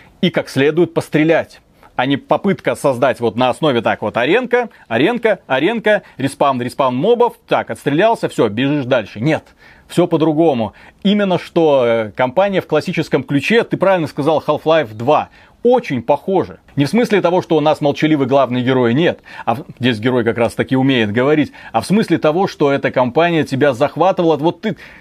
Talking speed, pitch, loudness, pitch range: 170 wpm, 155 Hz, -15 LUFS, 135-175 Hz